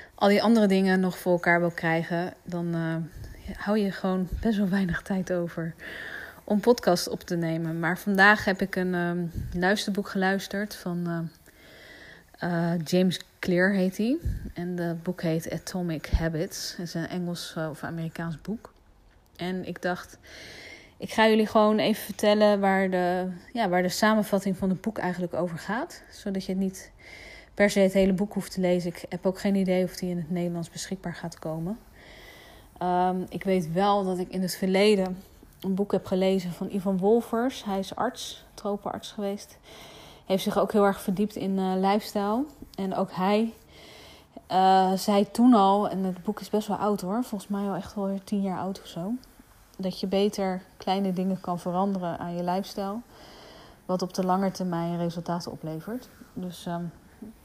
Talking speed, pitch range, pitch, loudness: 180 wpm, 175-200 Hz, 190 Hz, -27 LUFS